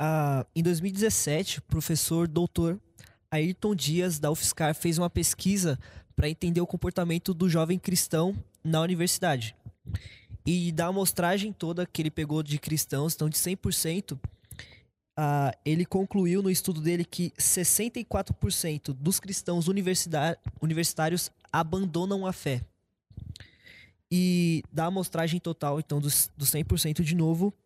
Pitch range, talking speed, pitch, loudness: 150-180 Hz, 125 wpm, 165 Hz, -28 LUFS